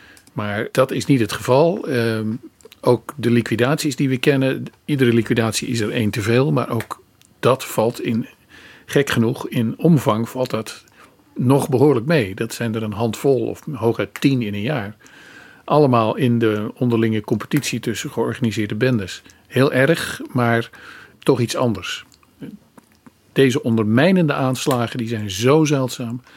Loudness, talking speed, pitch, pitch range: -19 LUFS, 150 wpm, 120 Hz, 115-135 Hz